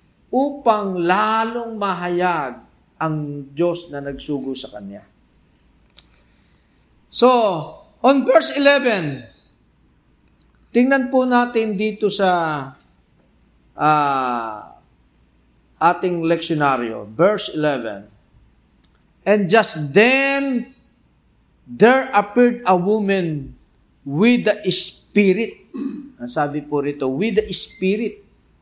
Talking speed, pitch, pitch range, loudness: 85 wpm, 185 Hz, 140-225 Hz, -19 LUFS